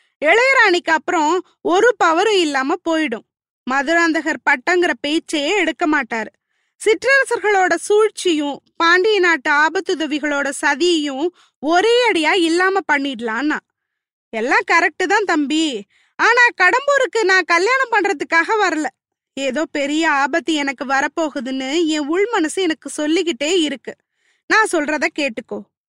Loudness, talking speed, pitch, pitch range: -16 LUFS, 100 wpm, 330 Hz, 295-375 Hz